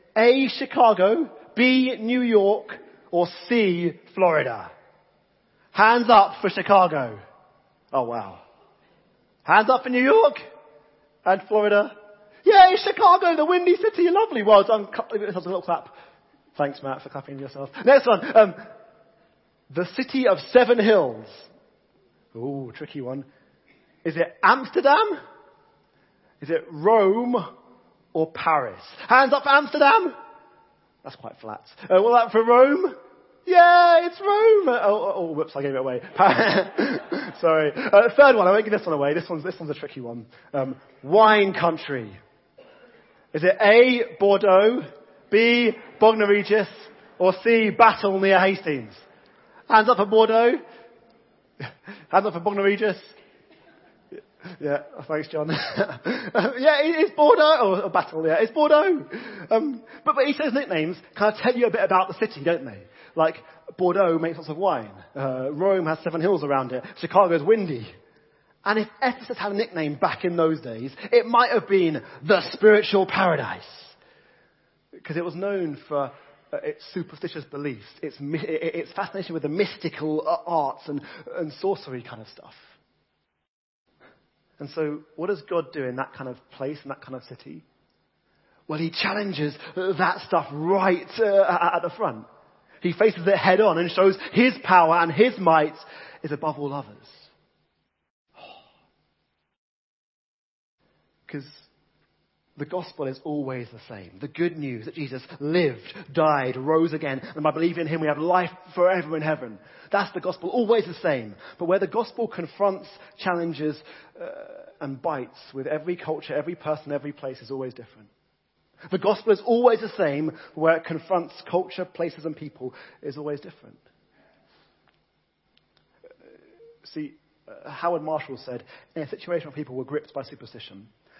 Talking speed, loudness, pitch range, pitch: 150 wpm, -21 LUFS, 150-220 Hz, 180 Hz